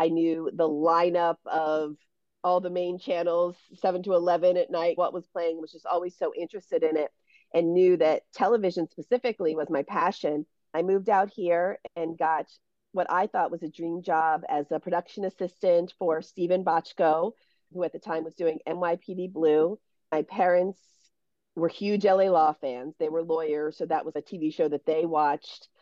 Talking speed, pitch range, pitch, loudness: 185 wpm, 160-180 Hz, 170 Hz, -27 LUFS